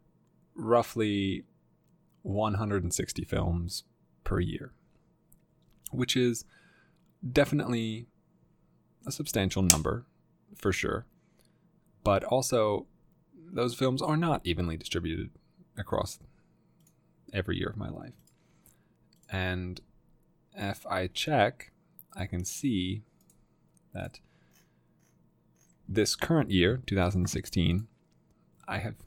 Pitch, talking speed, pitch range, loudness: 95 Hz, 85 wpm, 90-120 Hz, -30 LUFS